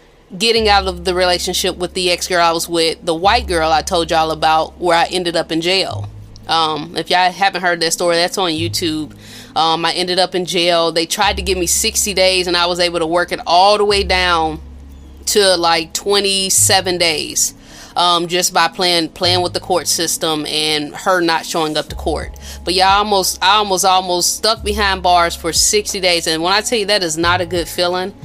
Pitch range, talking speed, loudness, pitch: 165-185 Hz, 215 wpm, -14 LUFS, 175 Hz